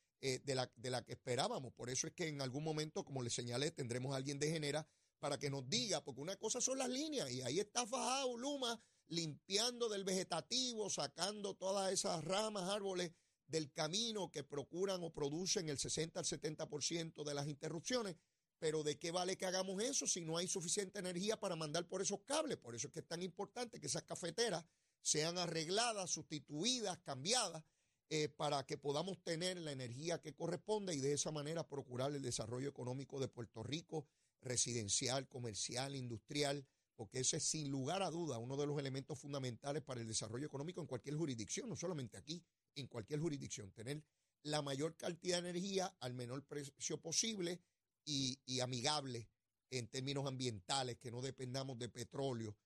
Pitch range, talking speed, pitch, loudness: 135-180 Hz, 180 wpm, 150 Hz, -43 LUFS